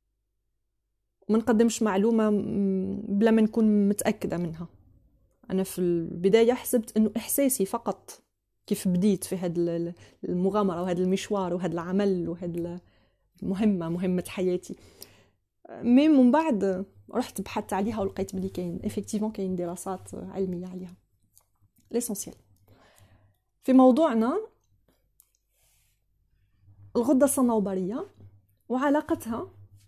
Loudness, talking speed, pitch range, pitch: -26 LUFS, 95 wpm, 130-215 Hz, 190 Hz